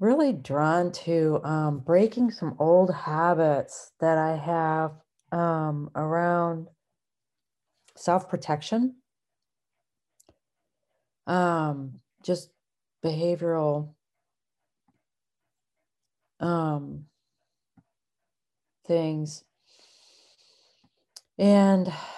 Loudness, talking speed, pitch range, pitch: -26 LUFS, 55 wpm, 155-180 Hz, 165 Hz